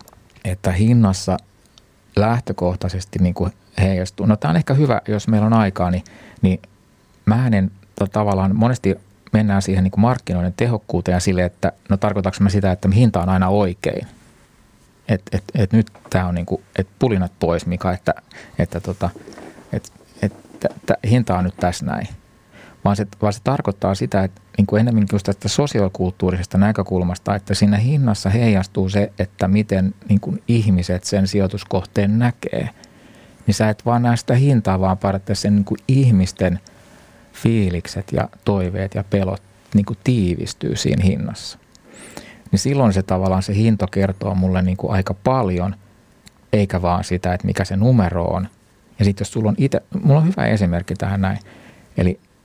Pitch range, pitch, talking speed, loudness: 95-110 Hz, 100 Hz, 160 wpm, -19 LUFS